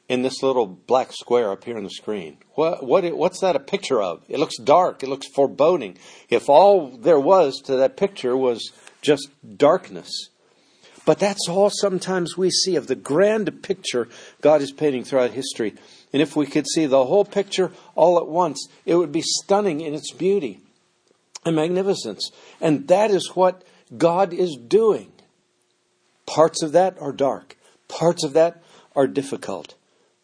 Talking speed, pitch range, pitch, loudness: 170 wpm, 135-185 Hz, 160 Hz, -21 LUFS